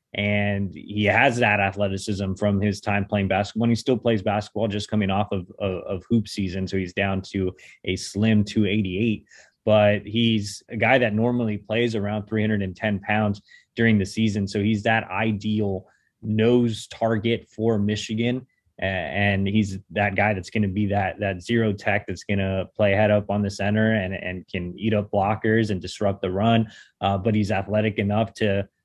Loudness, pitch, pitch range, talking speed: -23 LUFS, 105 Hz, 100-110 Hz, 195 wpm